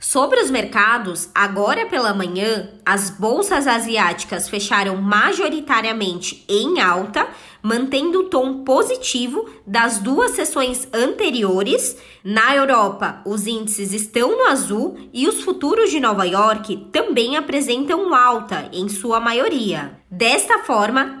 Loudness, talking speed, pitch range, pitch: -18 LUFS, 120 wpm, 205-285 Hz, 230 Hz